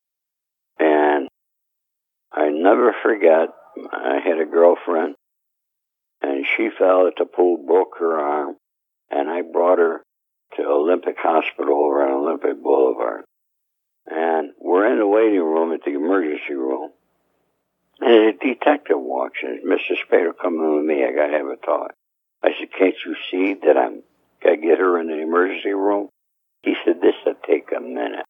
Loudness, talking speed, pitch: -19 LUFS, 160 wpm, 100 Hz